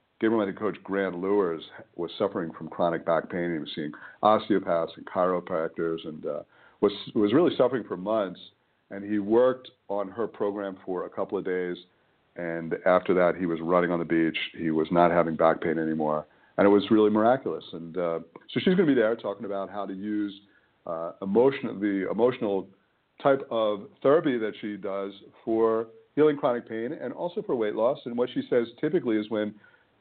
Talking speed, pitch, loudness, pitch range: 190 wpm, 100 Hz, -27 LUFS, 85-110 Hz